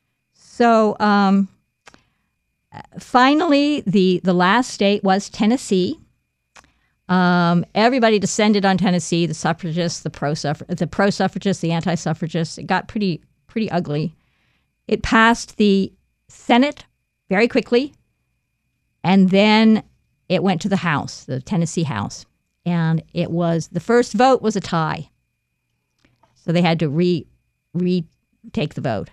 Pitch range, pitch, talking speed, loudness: 165-215 Hz, 185 Hz, 125 wpm, -18 LUFS